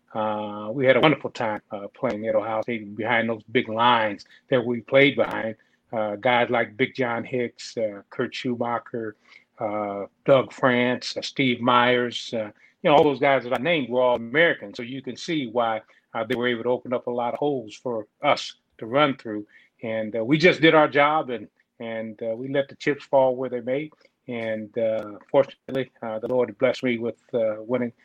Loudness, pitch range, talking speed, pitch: -24 LUFS, 110-130 Hz, 200 wpm, 120 Hz